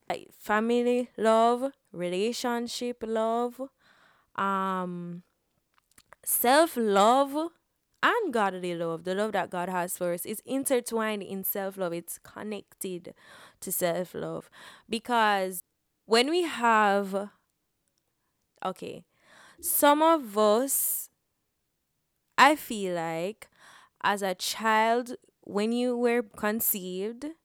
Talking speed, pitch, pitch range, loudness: 100 wpm, 215 Hz, 190-240 Hz, -27 LUFS